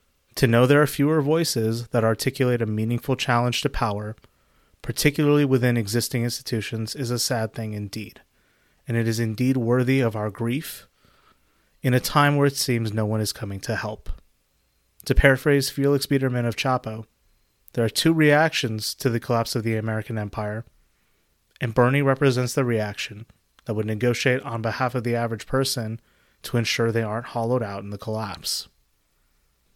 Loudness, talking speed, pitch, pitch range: -23 LUFS, 165 wpm, 115 Hz, 110-130 Hz